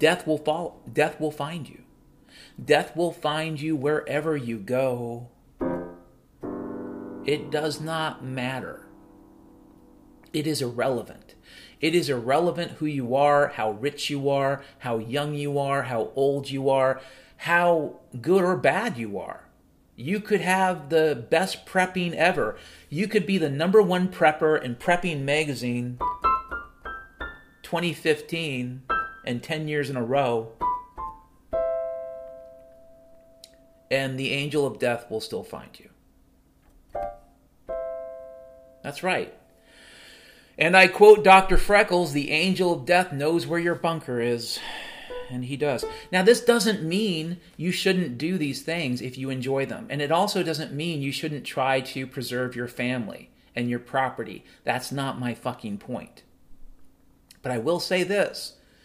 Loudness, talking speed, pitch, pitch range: -25 LUFS, 140 wpm, 145 Hz, 130-175 Hz